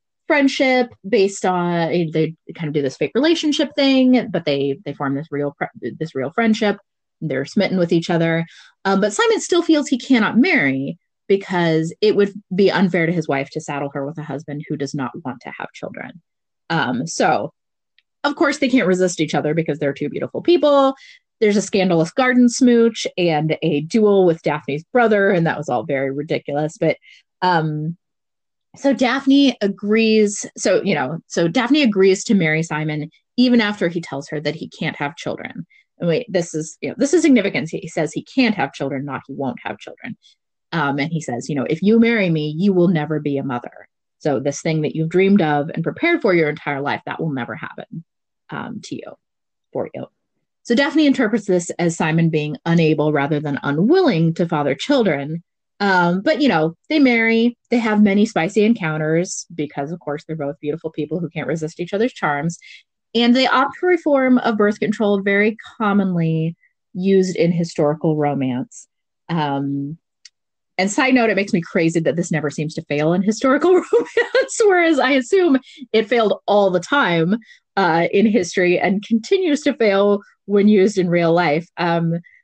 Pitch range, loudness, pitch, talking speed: 155-230 Hz, -18 LUFS, 180 Hz, 190 wpm